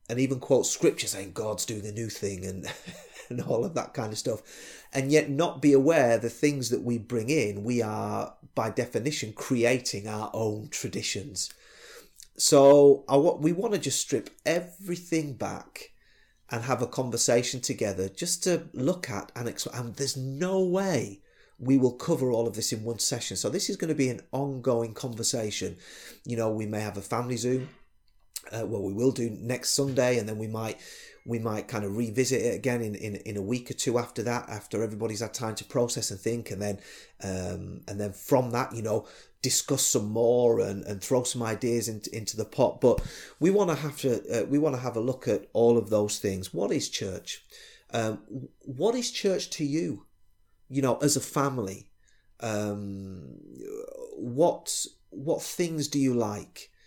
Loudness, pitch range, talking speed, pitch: -28 LUFS, 110-140 Hz, 195 wpm, 120 Hz